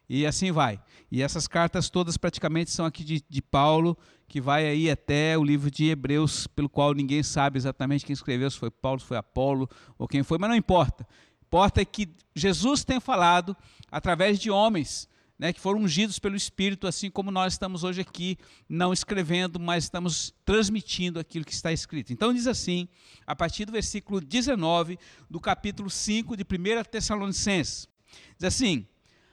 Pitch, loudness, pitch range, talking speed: 170 Hz, -27 LUFS, 145-195 Hz, 180 wpm